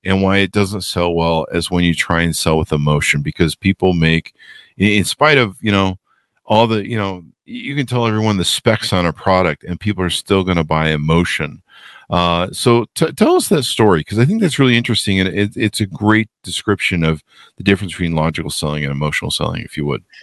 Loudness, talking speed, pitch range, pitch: -16 LUFS, 220 wpm, 85-110 Hz, 95 Hz